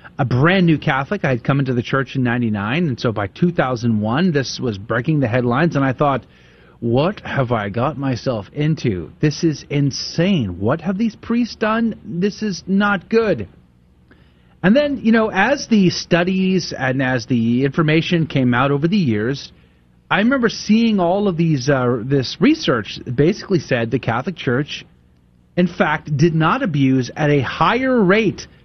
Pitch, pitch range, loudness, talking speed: 145 Hz, 125-185 Hz, -18 LUFS, 170 wpm